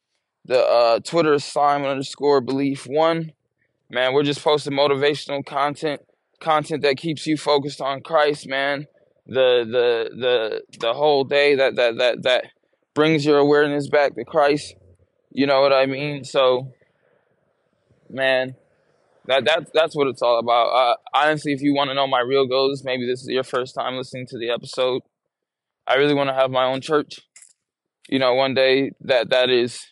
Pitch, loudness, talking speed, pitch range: 140 Hz, -20 LUFS, 175 wpm, 130-150 Hz